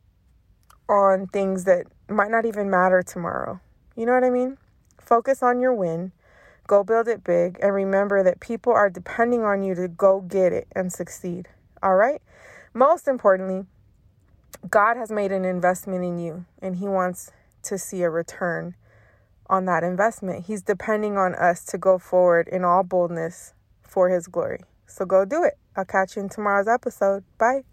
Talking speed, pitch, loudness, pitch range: 175 wpm, 190 Hz, -22 LUFS, 175-205 Hz